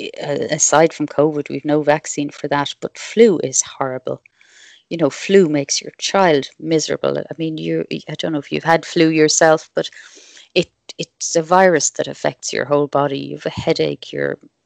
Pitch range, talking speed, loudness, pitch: 145-165 Hz, 190 wpm, -17 LUFS, 150 Hz